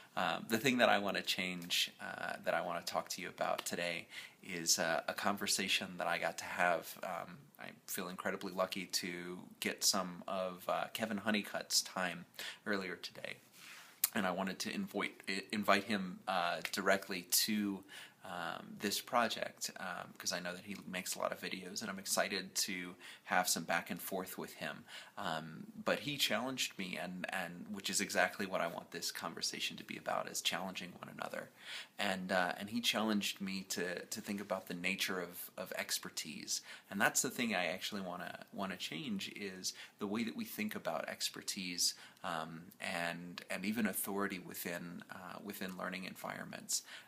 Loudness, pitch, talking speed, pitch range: -38 LUFS, 95 Hz, 180 wpm, 90-105 Hz